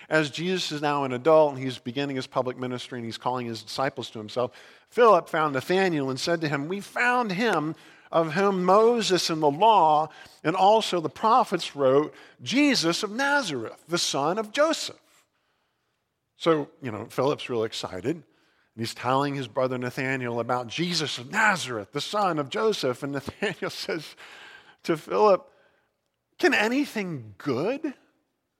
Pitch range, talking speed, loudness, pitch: 130-190 Hz, 155 wpm, -25 LUFS, 155 Hz